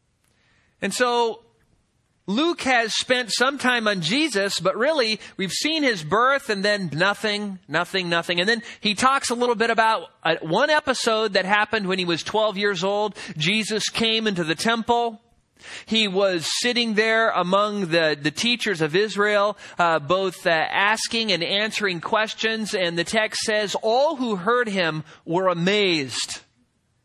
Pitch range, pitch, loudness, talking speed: 185-230 Hz, 210 Hz, -21 LUFS, 155 wpm